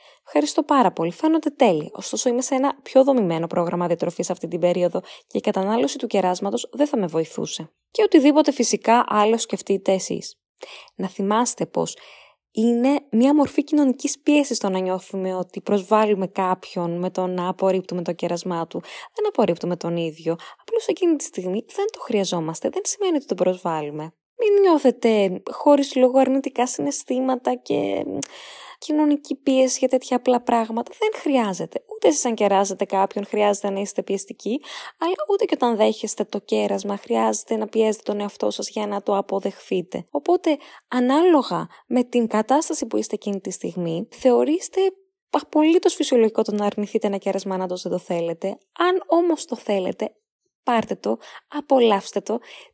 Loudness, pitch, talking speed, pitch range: -22 LUFS, 225 Hz, 160 wpm, 190-290 Hz